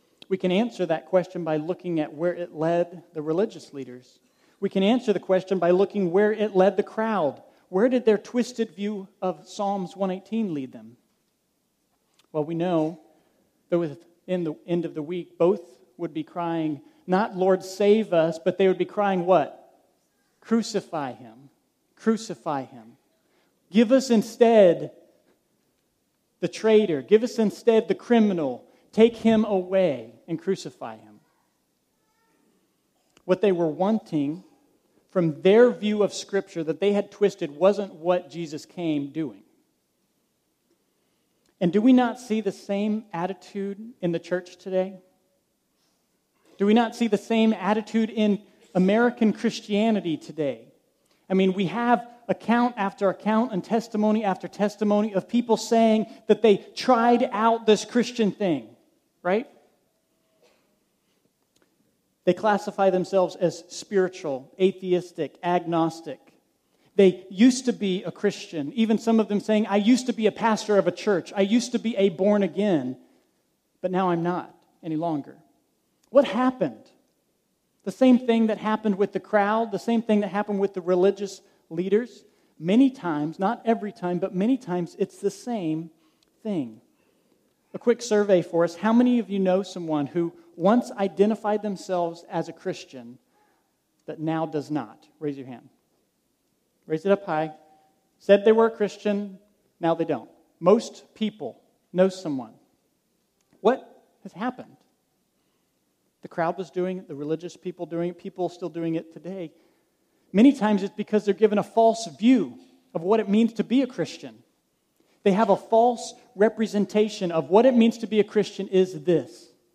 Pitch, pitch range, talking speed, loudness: 195 Hz, 175-220 Hz, 155 wpm, -24 LUFS